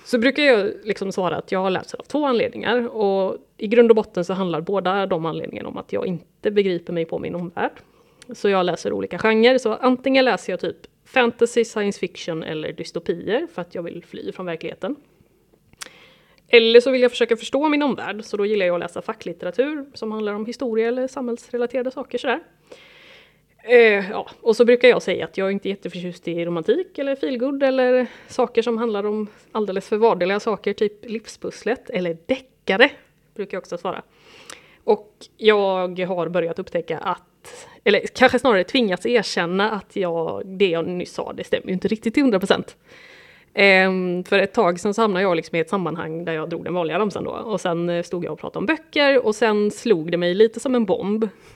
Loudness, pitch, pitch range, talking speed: -21 LUFS, 215 Hz, 185-245 Hz, 190 wpm